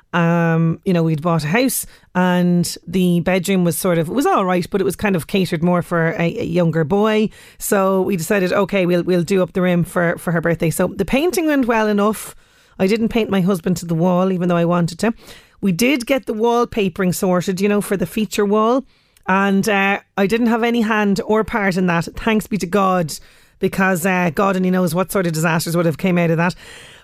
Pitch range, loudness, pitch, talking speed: 175-210 Hz, -17 LUFS, 190 Hz, 225 wpm